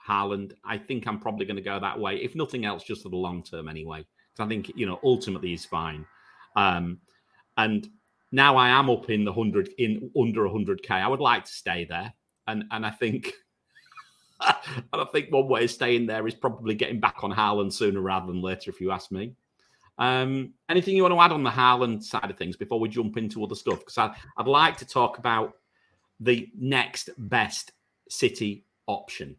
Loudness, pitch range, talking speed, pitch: -26 LUFS, 95-125 Hz, 205 wpm, 110 Hz